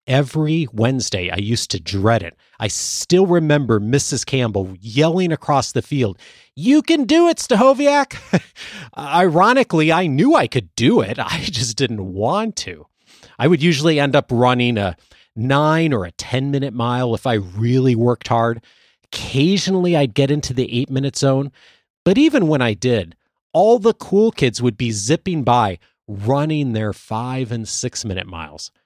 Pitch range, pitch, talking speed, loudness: 115-160 Hz, 130 Hz, 165 wpm, -17 LUFS